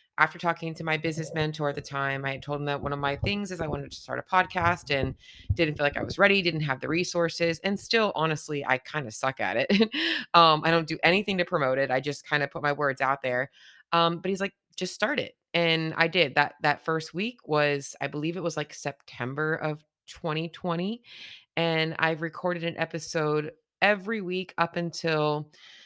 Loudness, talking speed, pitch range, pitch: -27 LUFS, 220 wpm, 145-175 Hz, 160 Hz